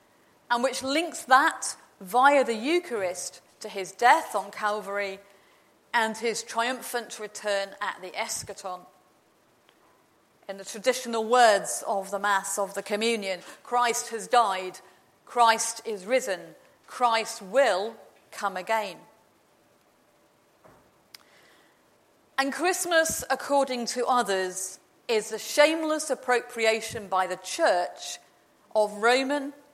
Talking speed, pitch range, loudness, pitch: 105 wpm, 200-255 Hz, -26 LUFS, 225 Hz